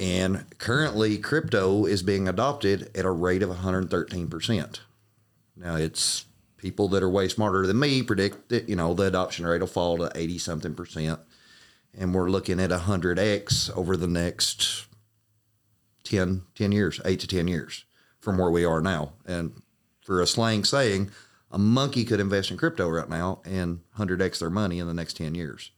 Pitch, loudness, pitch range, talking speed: 95 Hz, -26 LUFS, 85-105 Hz, 170 wpm